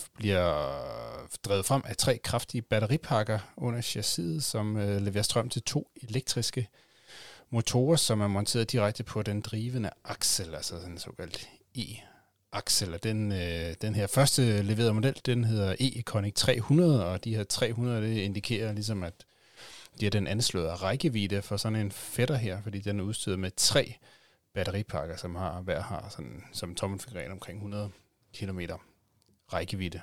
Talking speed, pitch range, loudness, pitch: 155 wpm, 100-120 Hz, -30 LUFS, 105 Hz